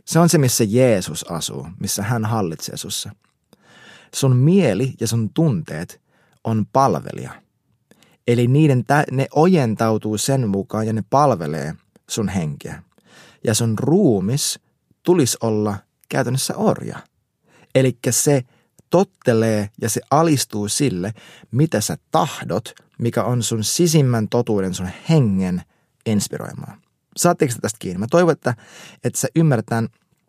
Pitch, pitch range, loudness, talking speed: 125 Hz, 110-150 Hz, -19 LUFS, 125 wpm